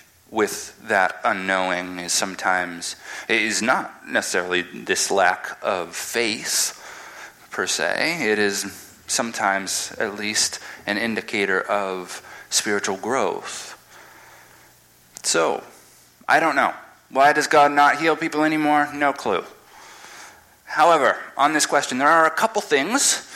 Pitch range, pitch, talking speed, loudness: 95-155 Hz, 110 Hz, 120 wpm, -21 LUFS